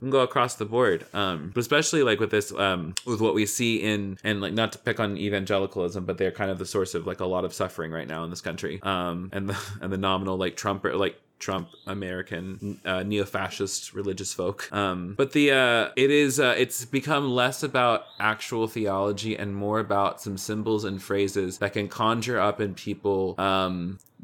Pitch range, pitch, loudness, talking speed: 95-115 Hz, 100 Hz, -26 LUFS, 205 wpm